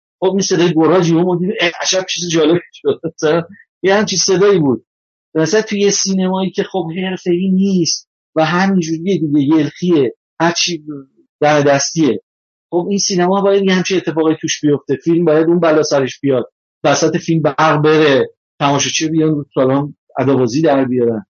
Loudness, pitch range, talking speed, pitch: -14 LUFS, 150-185 Hz, 150 wpm, 165 Hz